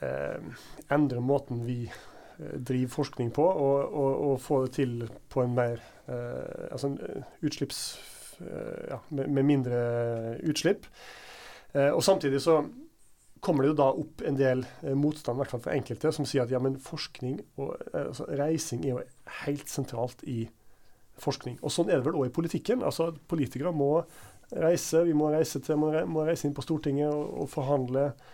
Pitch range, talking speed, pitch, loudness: 125-155 Hz, 170 wpm, 140 Hz, -30 LUFS